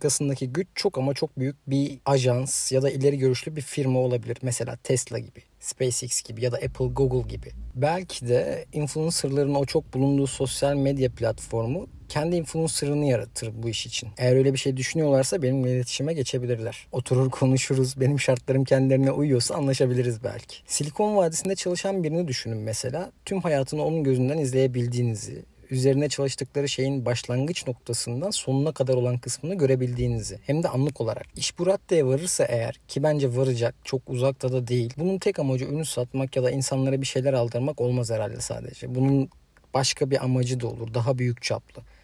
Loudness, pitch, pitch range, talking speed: -25 LUFS, 135 Hz, 125-145 Hz, 165 wpm